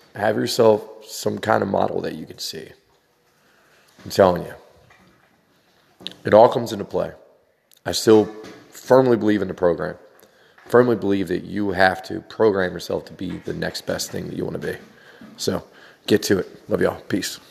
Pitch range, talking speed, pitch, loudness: 95-110 Hz, 175 wpm, 105 Hz, -21 LUFS